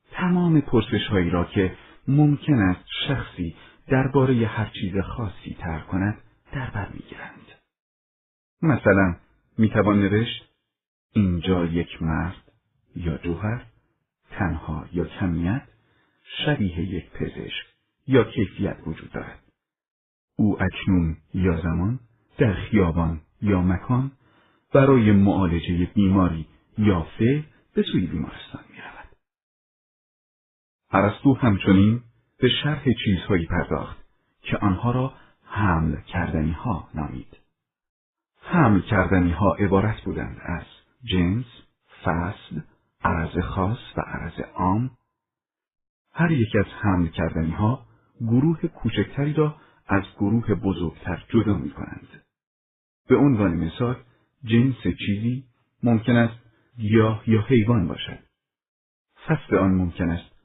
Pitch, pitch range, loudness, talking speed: 105 Hz, 90-120 Hz, -23 LUFS, 110 wpm